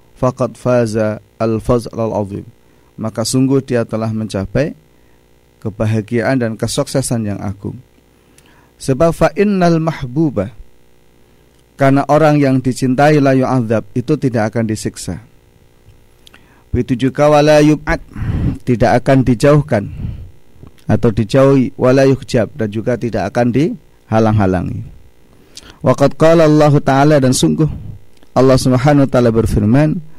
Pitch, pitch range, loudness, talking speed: 120 Hz, 105-135 Hz, -14 LUFS, 105 wpm